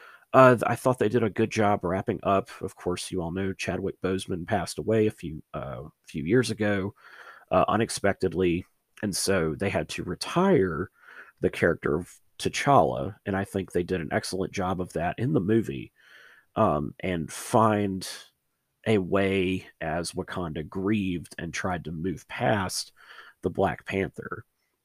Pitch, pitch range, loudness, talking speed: 95 Hz, 90-105 Hz, -27 LUFS, 160 wpm